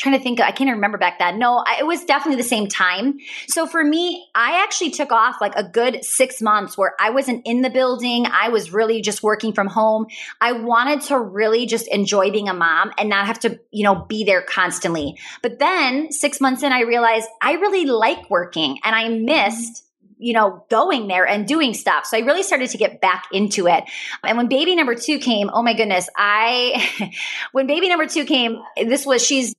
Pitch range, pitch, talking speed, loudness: 210-275 Hz, 235 Hz, 215 wpm, -18 LUFS